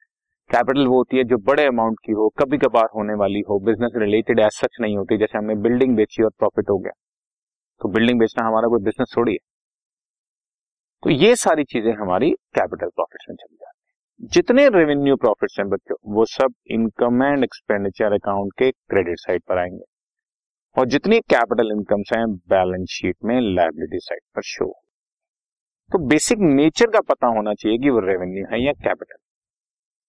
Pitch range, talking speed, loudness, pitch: 105-140 Hz, 175 wpm, -19 LUFS, 115 Hz